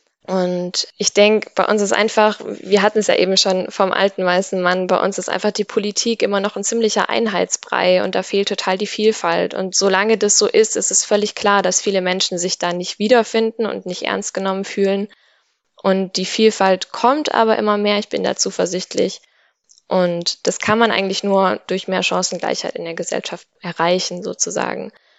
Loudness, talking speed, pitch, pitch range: -17 LUFS, 190 wpm, 200 Hz, 185-215 Hz